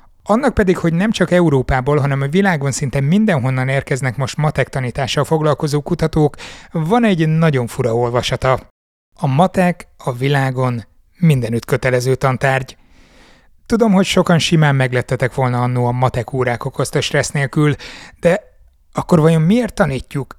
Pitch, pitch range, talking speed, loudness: 140 Hz, 130-165 Hz, 140 wpm, -16 LUFS